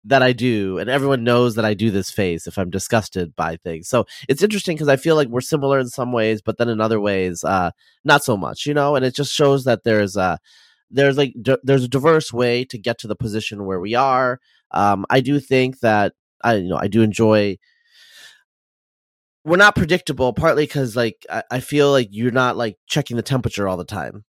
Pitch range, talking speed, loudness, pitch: 110-140 Hz, 225 wpm, -19 LUFS, 125 Hz